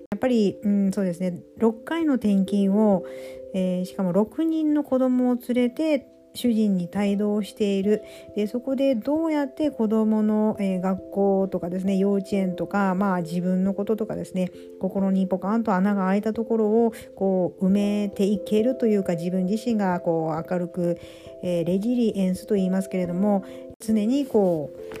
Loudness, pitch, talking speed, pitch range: -24 LUFS, 200 Hz, 325 characters per minute, 185-225 Hz